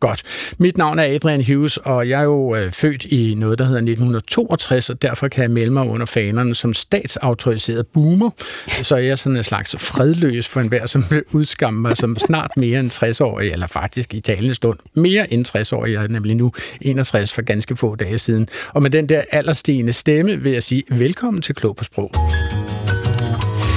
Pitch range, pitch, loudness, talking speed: 115-145 Hz, 125 Hz, -18 LUFS, 200 wpm